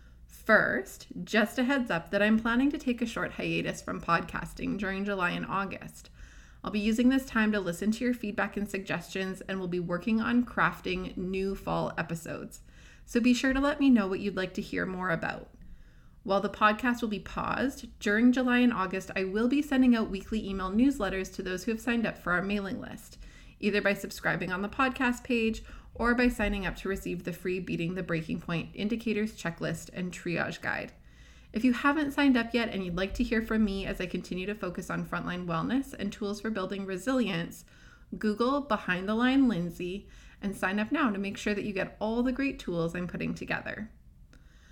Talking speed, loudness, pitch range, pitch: 205 wpm, -30 LUFS, 185-235 Hz, 205 Hz